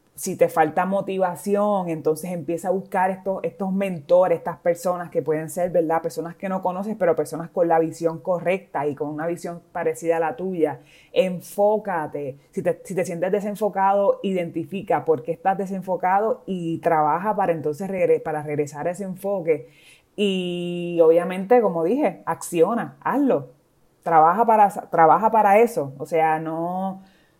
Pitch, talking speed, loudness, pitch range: 175 Hz, 155 wpm, -22 LUFS, 165-195 Hz